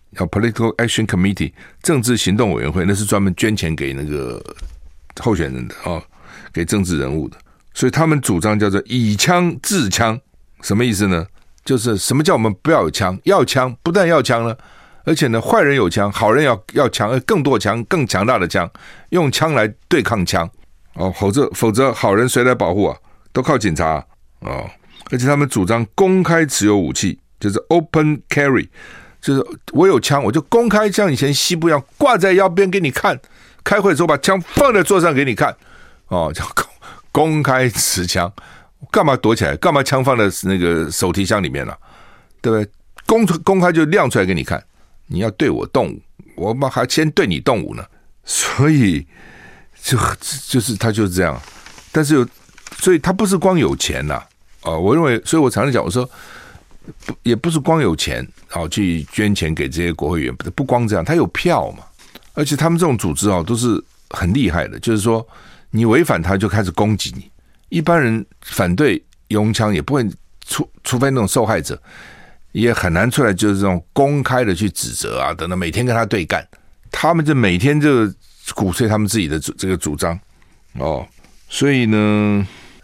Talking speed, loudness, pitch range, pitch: 290 characters per minute, -16 LUFS, 95-145 Hz, 115 Hz